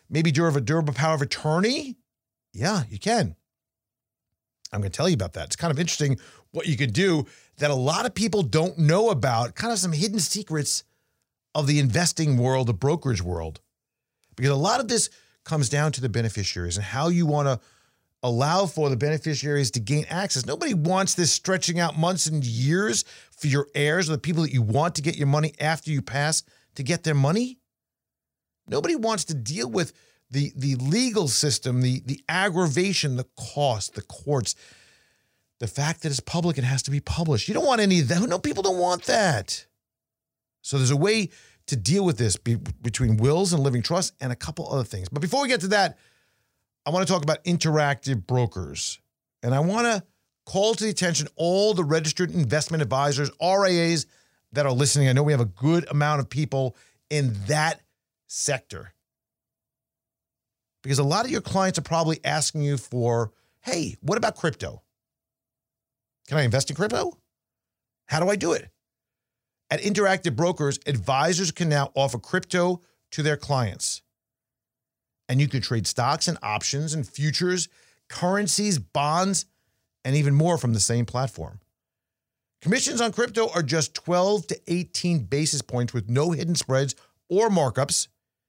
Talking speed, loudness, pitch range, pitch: 180 wpm, -24 LUFS, 130-175 Hz, 150 Hz